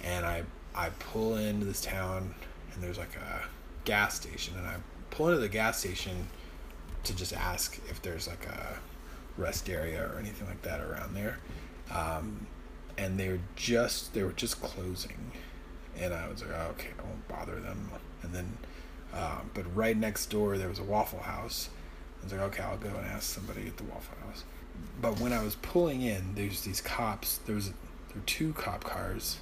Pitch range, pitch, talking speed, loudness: 85-105 Hz, 95 Hz, 190 wpm, -35 LUFS